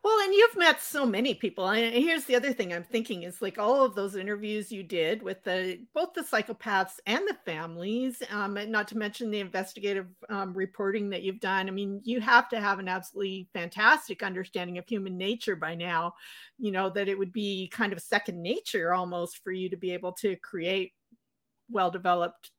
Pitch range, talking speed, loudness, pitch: 185-230 Hz, 200 wpm, -29 LUFS, 200 Hz